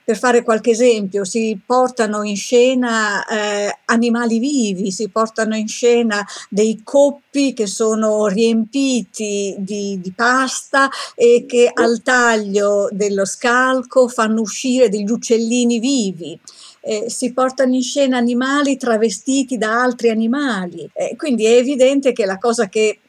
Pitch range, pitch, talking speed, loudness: 215-255 Hz, 235 Hz, 135 wpm, -16 LUFS